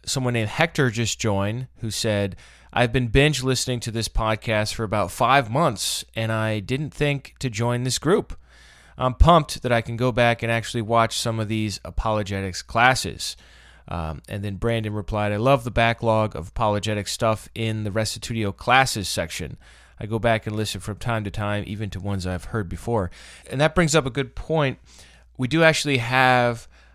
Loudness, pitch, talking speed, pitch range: -23 LUFS, 110 Hz, 185 wpm, 105-125 Hz